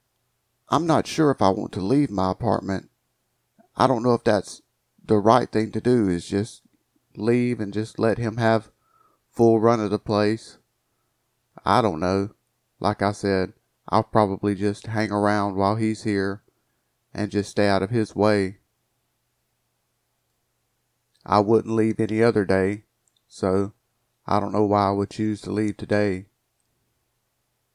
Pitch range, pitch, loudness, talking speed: 100-120 Hz, 110 Hz, -23 LUFS, 155 wpm